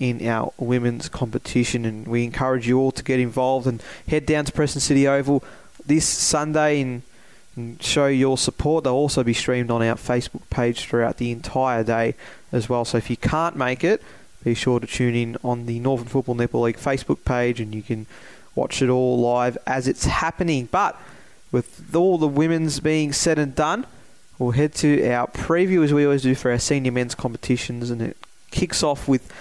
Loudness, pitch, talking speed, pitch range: -22 LUFS, 125 Hz, 200 wpm, 120-145 Hz